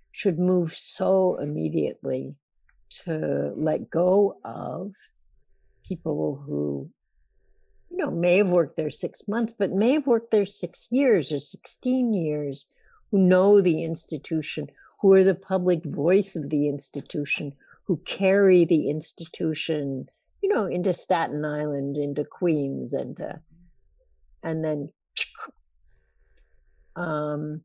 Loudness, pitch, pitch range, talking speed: -25 LUFS, 165 Hz, 145-190 Hz, 120 wpm